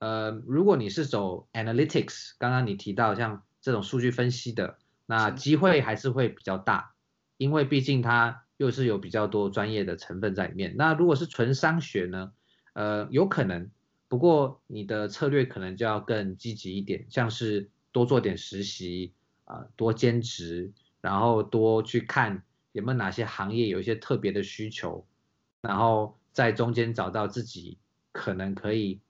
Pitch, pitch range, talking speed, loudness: 110 Hz, 100-125 Hz, 265 characters per minute, -28 LUFS